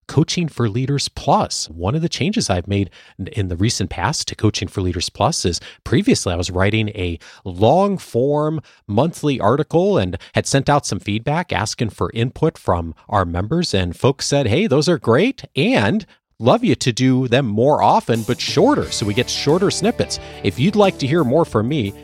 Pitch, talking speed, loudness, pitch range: 115 Hz, 195 wpm, -18 LUFS, 95-145 Hz